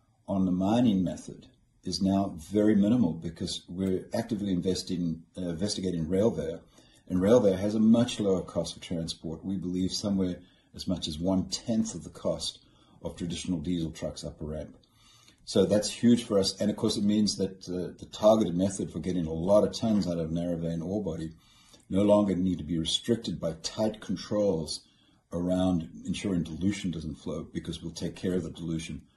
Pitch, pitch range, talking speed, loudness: 95 Hz, 85-105 Hz, 185 wpm, -29 LUFS